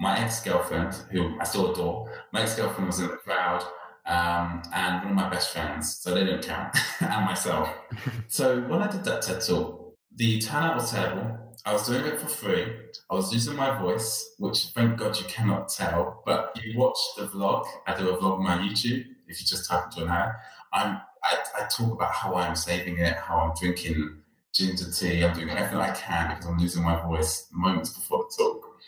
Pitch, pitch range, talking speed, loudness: 95 Hz, 85-115 Hz, 210 wpm, -27 LUFS